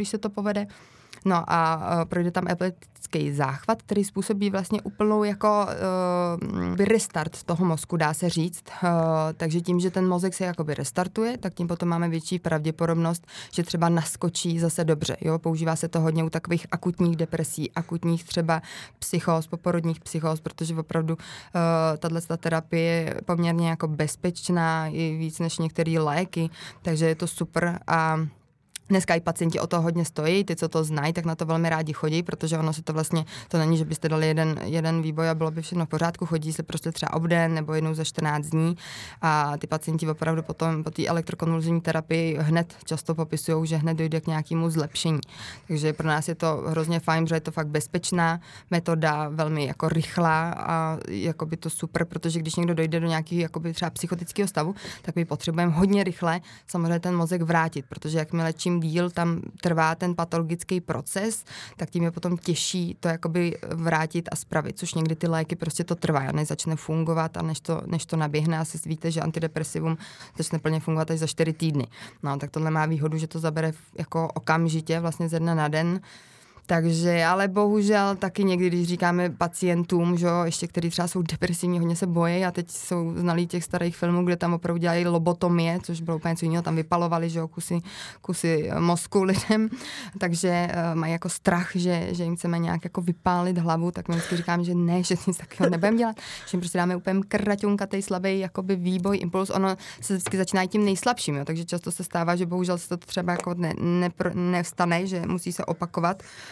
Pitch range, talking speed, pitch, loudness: 160-175 Hz, 195 wpm, 170 Hz, -26 LUFS